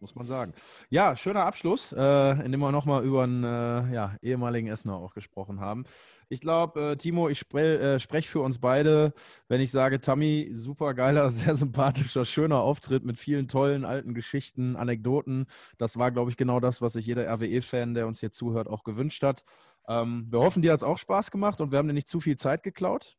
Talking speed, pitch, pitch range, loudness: 210 wpm, 130 Hz, 120-145 Hz, -27 LUFS